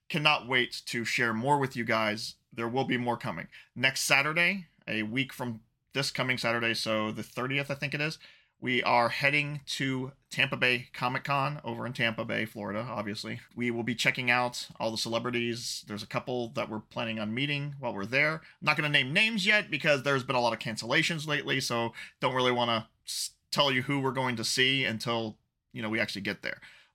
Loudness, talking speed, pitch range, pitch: -29 LUFS, 210 wpm, 115-140 Hz, 125 Hz